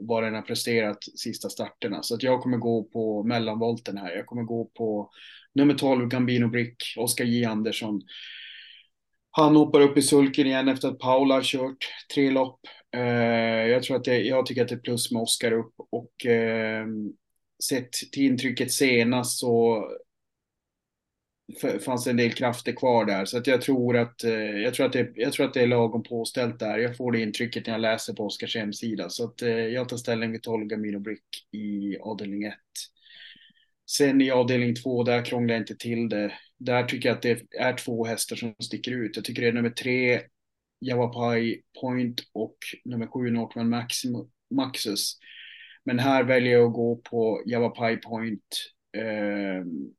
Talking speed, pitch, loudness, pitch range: 175 wpm, 120 Hz, -26 LUFS, 115-125 Hz